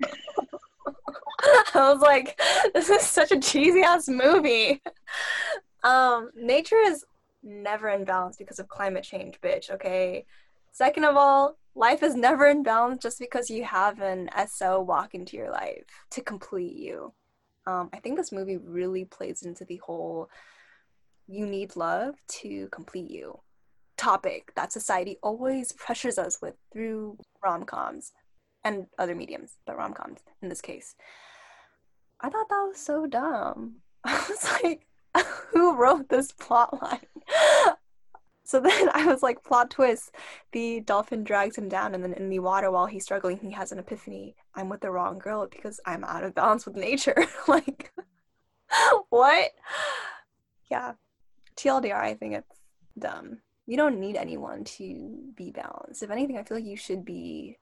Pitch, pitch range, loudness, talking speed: 235 Hz, 195-290 Hz, -25 LUFS, 155 wpm